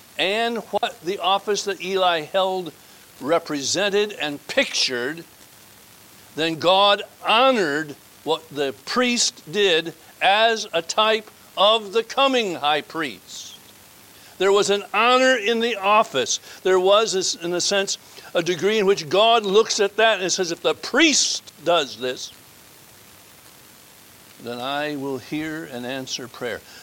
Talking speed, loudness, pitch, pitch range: 130 wpm, -20 LUFS, 190 Hz, 150-215 Hz